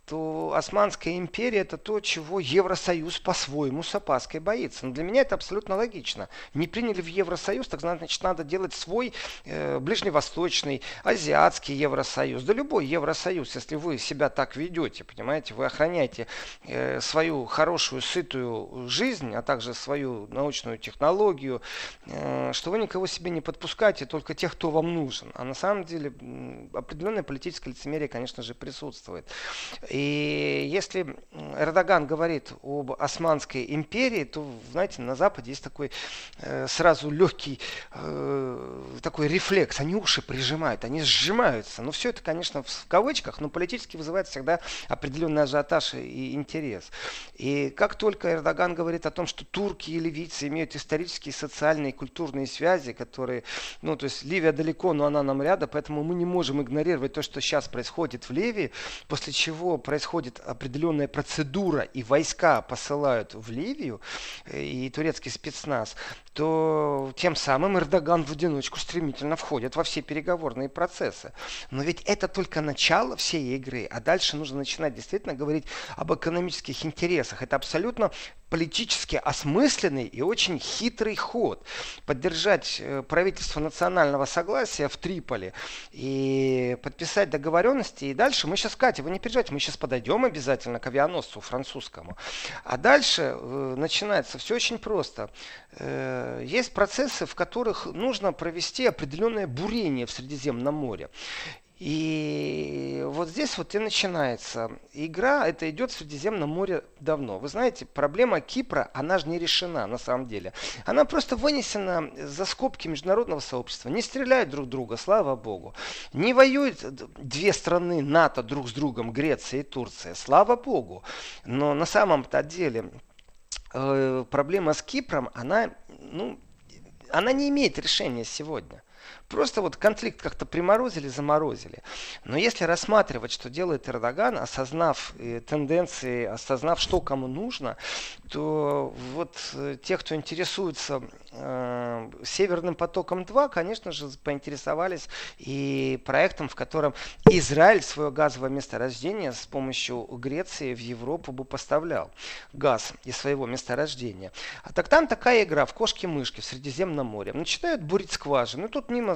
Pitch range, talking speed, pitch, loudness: 135-180 Hz, 135 wpm, 155 Hz, -27 LUFS